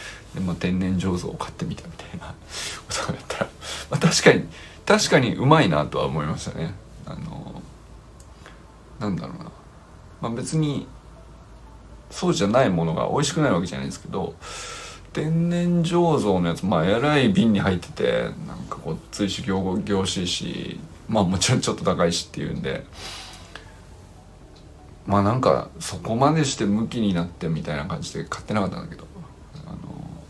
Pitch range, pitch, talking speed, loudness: 90-110 Hz, 95 Hz, 325 characters per minute, -23 LUFS